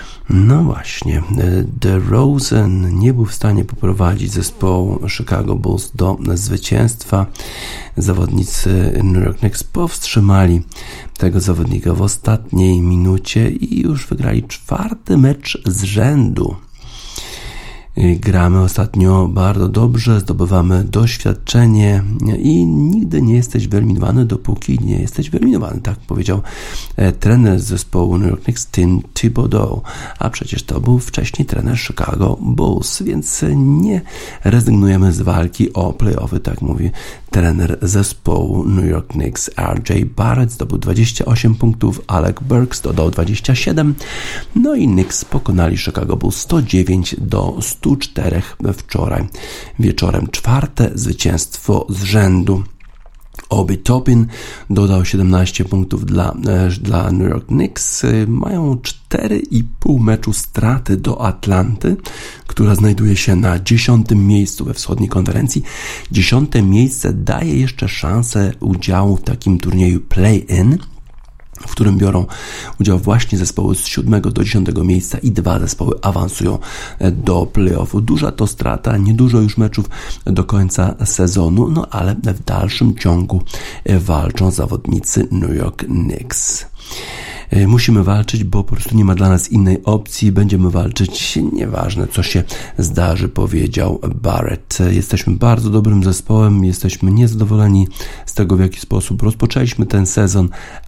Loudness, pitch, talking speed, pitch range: -15 LUFS, 100 Hz, 125 wpm, 95-115 Hz